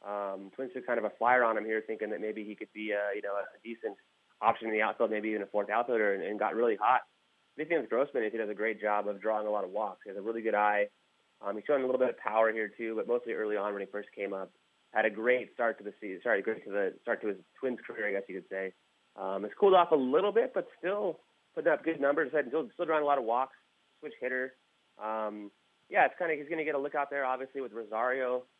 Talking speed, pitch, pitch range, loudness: 280 wpm, 110 Hz, 105-130 Hz, -32 LUFS